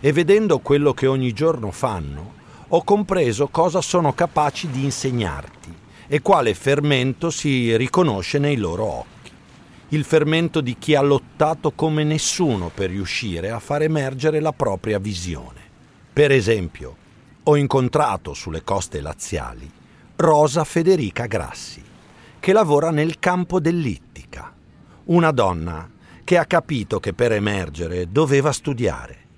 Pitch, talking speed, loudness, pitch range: 140 Hz, 130 wpm, -20 LUFS, 100-155 Hz